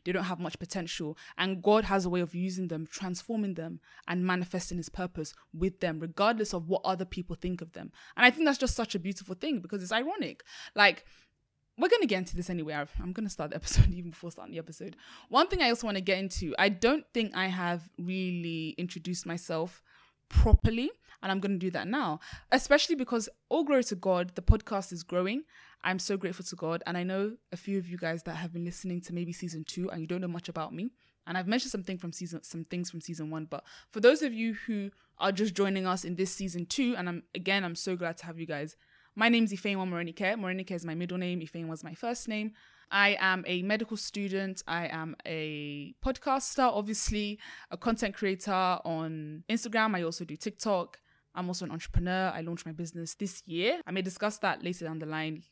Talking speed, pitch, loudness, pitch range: 225 wpm, 185 Hz, -31 LUFS, 170-205 Hz